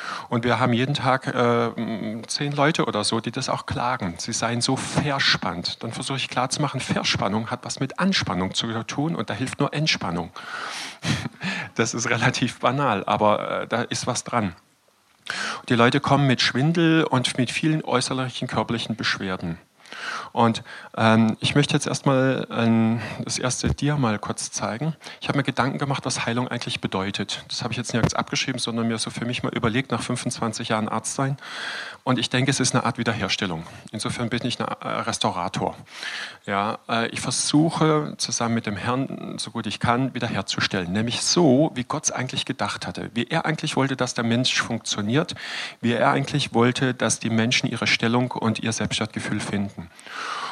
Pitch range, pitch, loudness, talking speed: 115-135 Hz, 120 Hz, -23 LUFS, 175 wpm